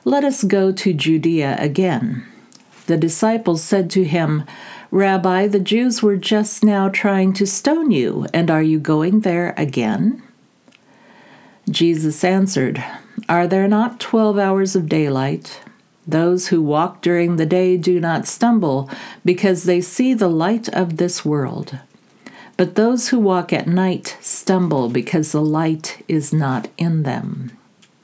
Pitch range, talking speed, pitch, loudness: 160-200 Hz, 145 wpm, 180 Hz, -17 LUFS